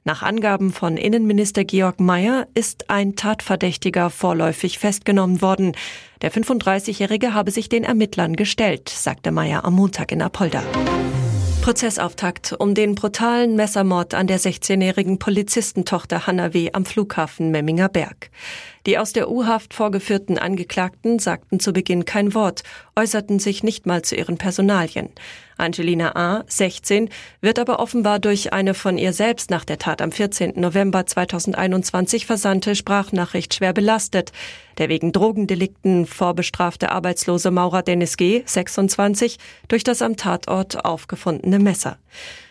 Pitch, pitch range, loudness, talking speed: 190 Hz, 180-210 Hz, -20 LUFS, 135 wpm